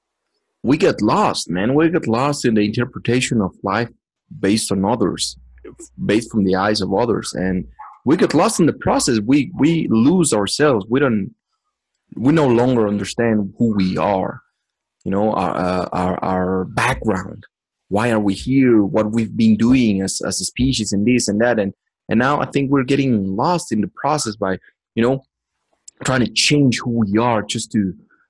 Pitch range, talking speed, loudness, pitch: 95-125 Hz, 180 wpm, -18 LUFS, 110 Hz